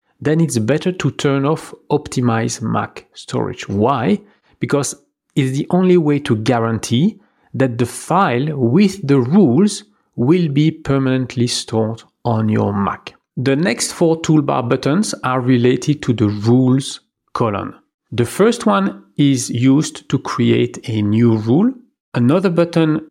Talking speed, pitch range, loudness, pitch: 140 wpm, 120-165 Hz, -16 LUFS, 140 Hz